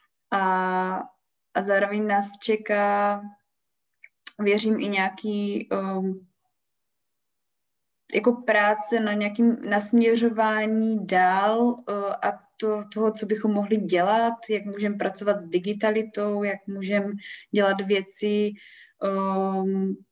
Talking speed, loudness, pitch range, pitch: 100 wpm, -24 LUFS, 195-215 Hz, 205 Hz